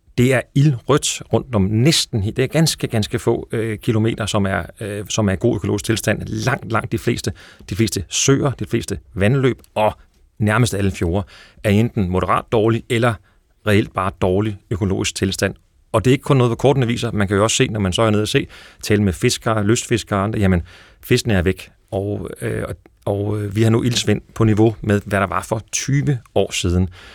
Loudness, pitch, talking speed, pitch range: -19 LUFS, 110 Hz, 210 wpm, 100-120 Hz